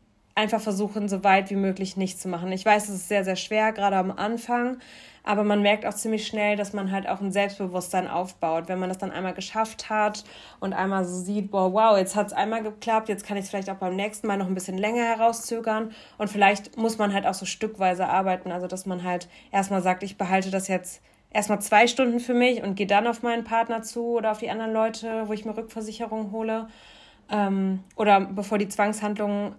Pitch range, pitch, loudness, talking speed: 190-220 Hz, 205 Hz, -25 LUFS, 220 wpm